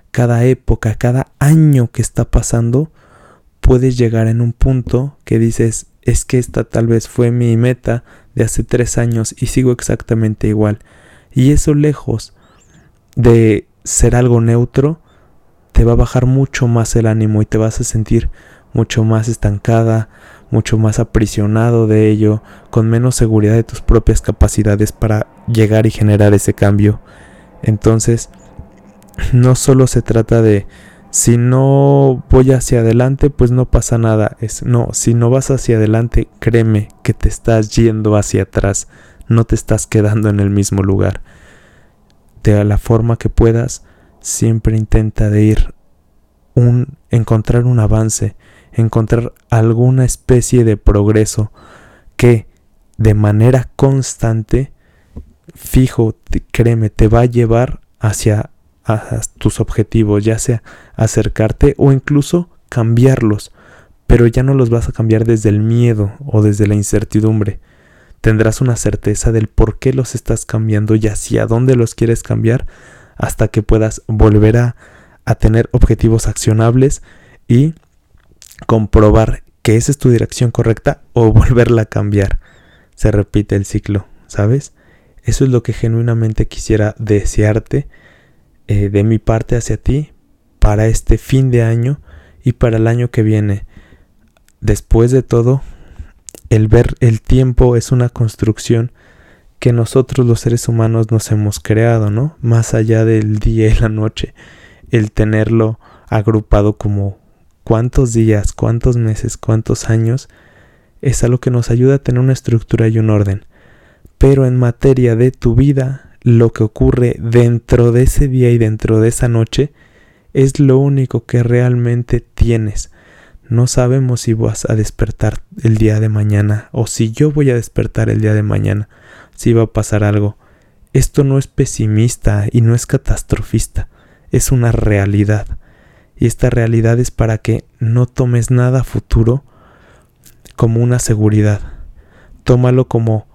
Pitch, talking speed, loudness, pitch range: 115 Hz, 145 wpm, -13 LUFS, 105-120 Hz